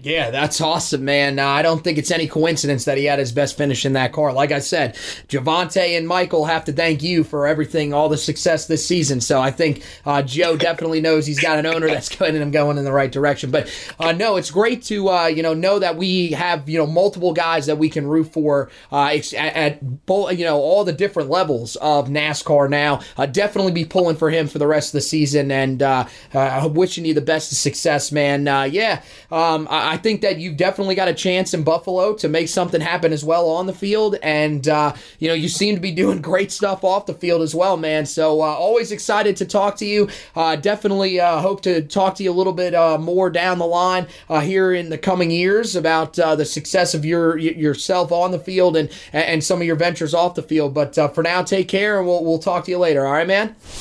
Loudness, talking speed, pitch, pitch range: -18 LUFS, 240 wpm, 165 Hz, 150-180 Hz